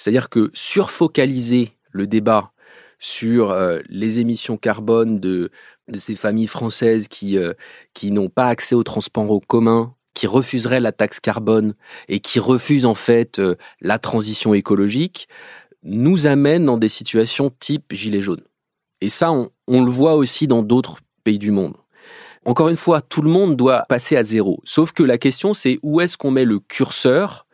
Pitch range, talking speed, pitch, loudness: 110-135 Hz, 175 wpm, 120 Hz, -17 LUFS